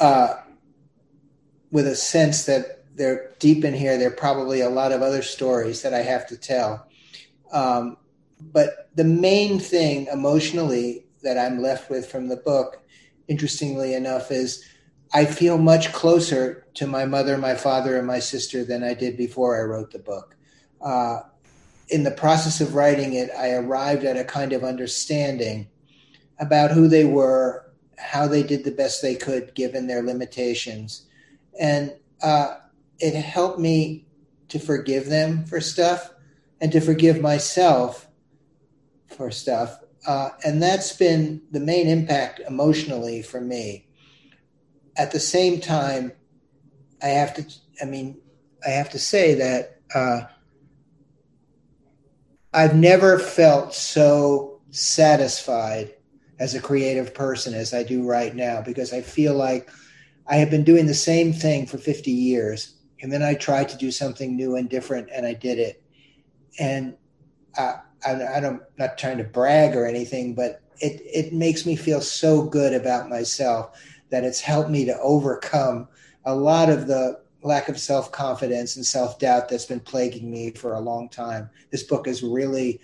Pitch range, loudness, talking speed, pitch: 130-150 Hz, -22 LUFS, 160 wpm, 140 Hz